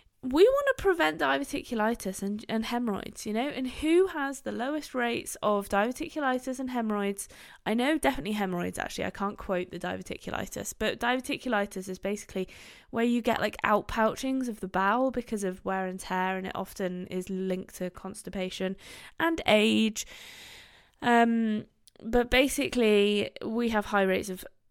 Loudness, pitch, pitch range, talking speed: -29 LUFS, 215 Hz, 190-255 Hz, 160 wpm